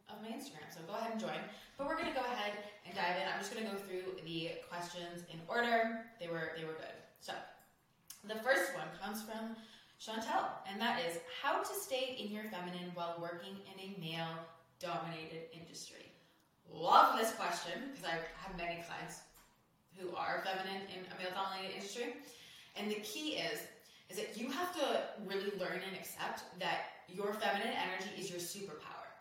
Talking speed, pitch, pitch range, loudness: 185 wpm, 190 Hz, 170-225 Hz, -40 LUFS